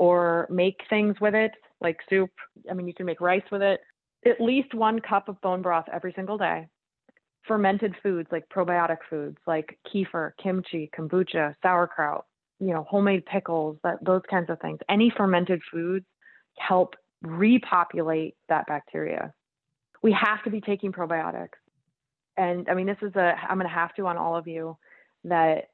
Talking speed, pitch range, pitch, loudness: 170 wpm, 165-200 Hz, 180 Hz, -26 LUFS